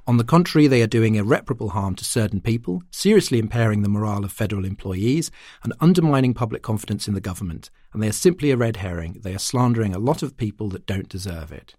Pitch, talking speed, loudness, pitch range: 110 Hz, 220 wpm, -21 LUFS, 100-130 Hz